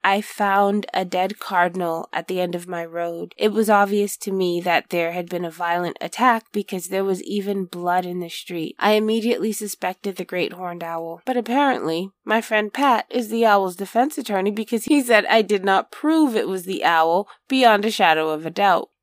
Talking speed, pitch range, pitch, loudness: 205 wpm, 175-215 Hz, 195 Hz, -21 LUFS